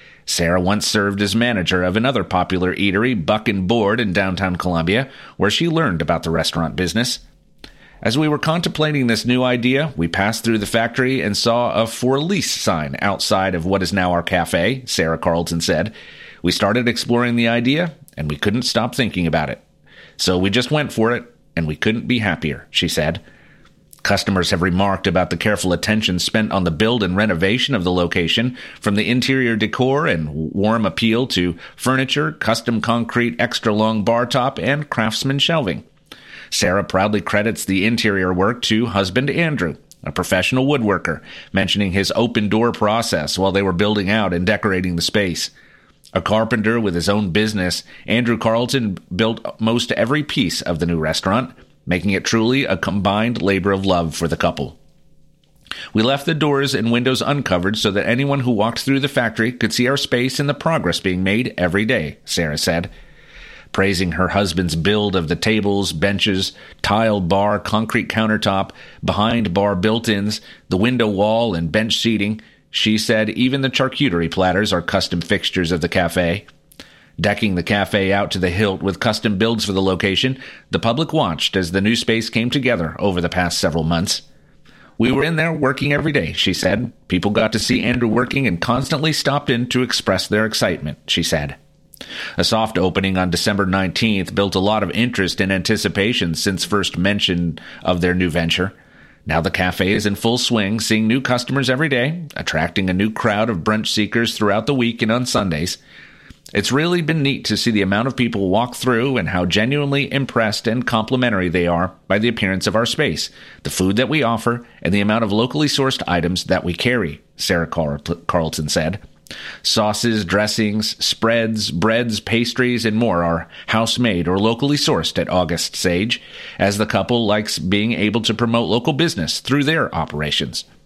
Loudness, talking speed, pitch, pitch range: -18 LUFS, 180 wpm, 105 Hz, 95-120 Hz